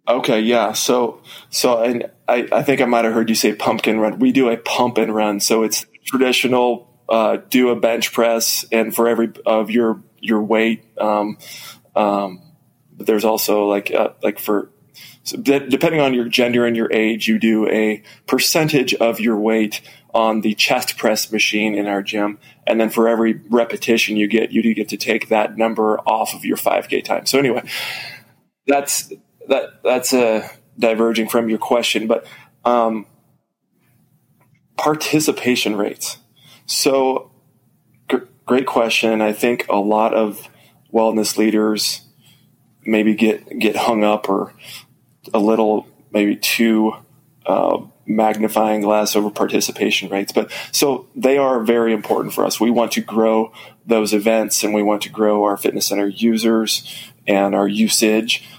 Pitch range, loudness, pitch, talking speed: 110-120 Hz, -17 LUFS, 110 Hz, 160 wpm